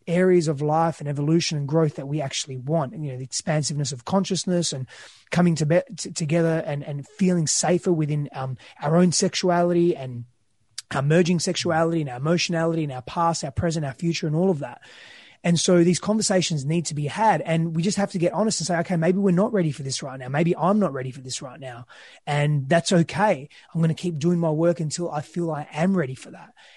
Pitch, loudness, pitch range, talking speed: 165 Hz, -23 LUFS, 145-175 Hz, 230 wpm